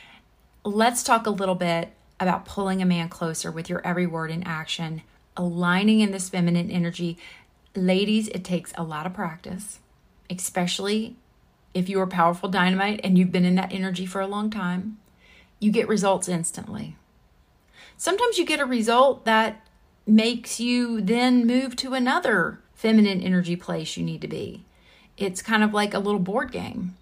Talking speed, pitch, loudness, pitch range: 165 wpm, 195 Hz, -24 LUFS, 180-220 Hz